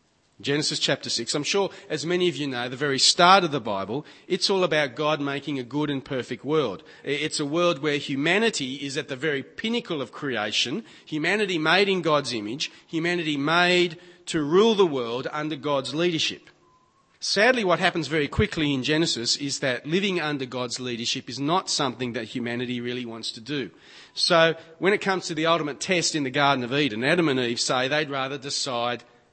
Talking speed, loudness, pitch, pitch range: 190 wpm, -24 LUFS, 150 Hz, 130-170 Hz